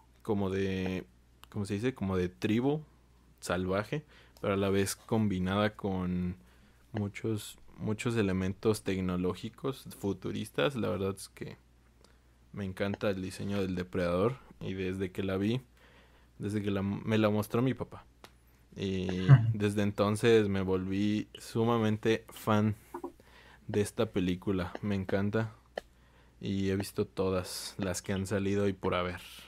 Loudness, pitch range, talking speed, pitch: -32 LUFS, 90-105 Hz, 135 wpm, 100 Hz